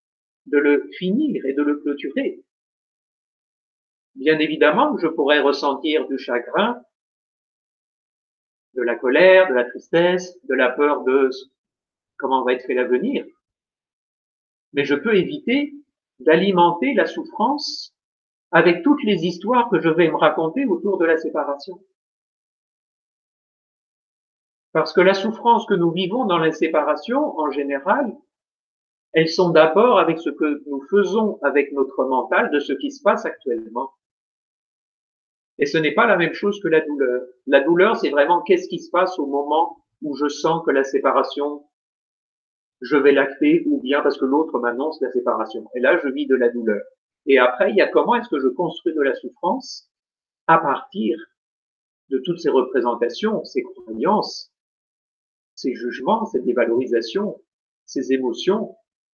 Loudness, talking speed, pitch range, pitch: -19 LUFS, 150 wpm, 145-210 Hz, 165 Hz